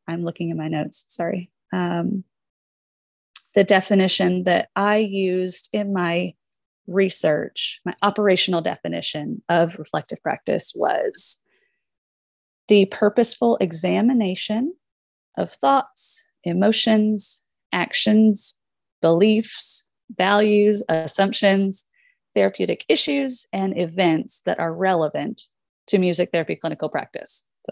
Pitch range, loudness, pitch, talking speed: 170-215 Hz, -21 LUFS, 190 Hz, 95 wpm